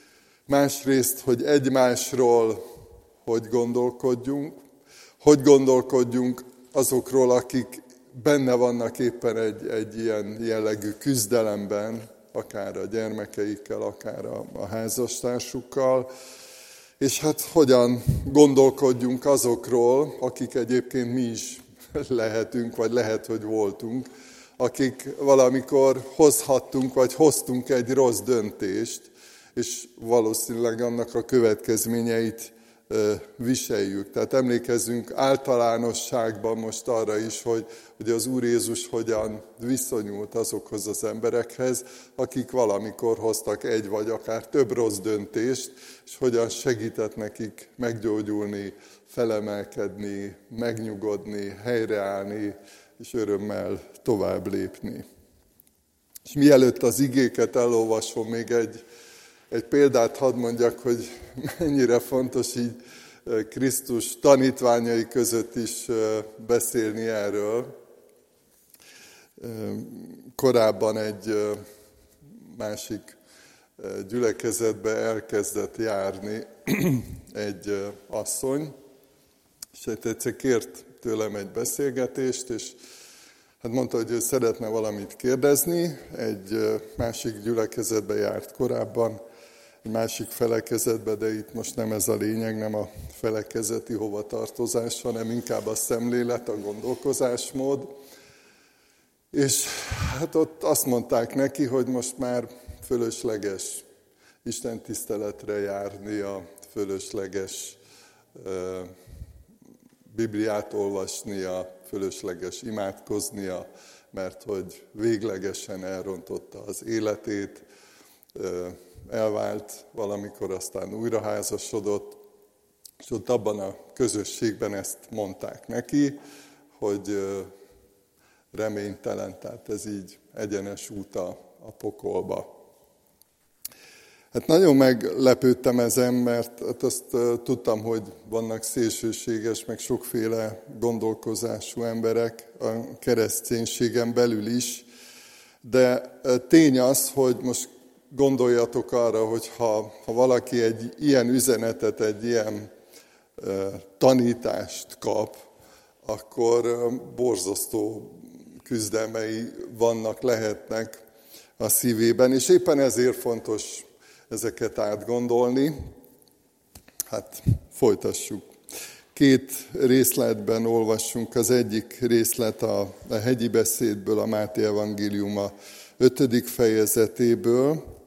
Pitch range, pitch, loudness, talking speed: 110-125 Hz, 115 Hz, -25 LUFS, 95 wpm